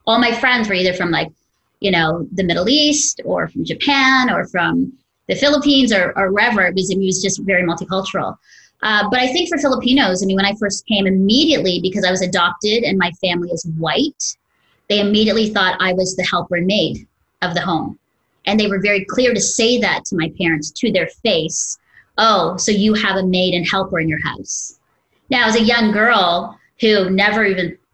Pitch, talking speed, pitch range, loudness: 200 Hz, 205 wpm, 185-235 Hz, -16 LUFS